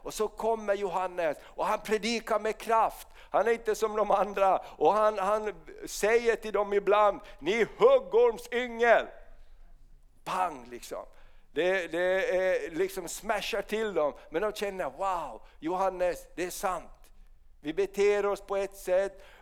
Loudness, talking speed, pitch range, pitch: -29 LUFS, 140 wpm, 195-230 Hz, 210 Hz